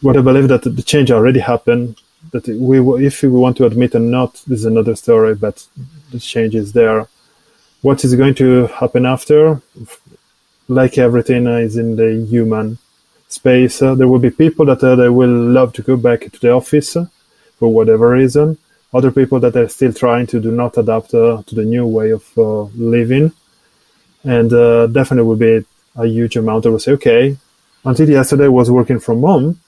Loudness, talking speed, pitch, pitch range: -12 LUFS, 200 wpm, 125 Hz, 115-135 Hz